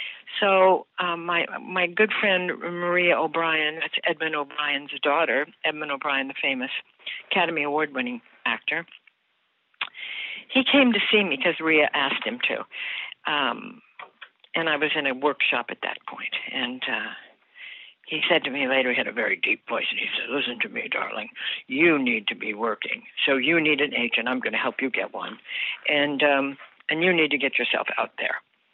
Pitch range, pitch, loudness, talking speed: 150-245 Hz, 170 Hz, -24 LUFS, 180 wpm